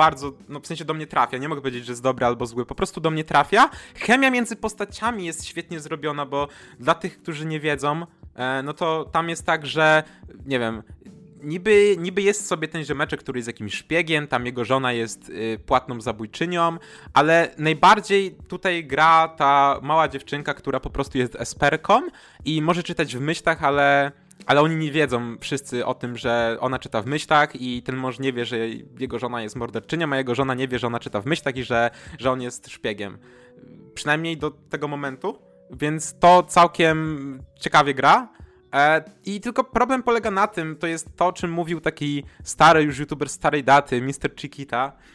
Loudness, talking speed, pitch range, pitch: -22 LUFS, 185 wpm, 130-165 Hz, 150 Hz